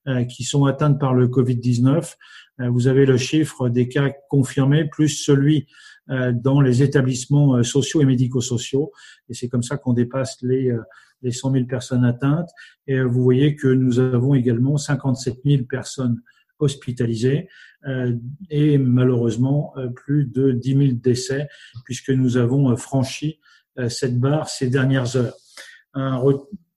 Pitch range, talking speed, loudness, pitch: 125-140 Hz, 135 wpm, -20 LUFS, 130 Hz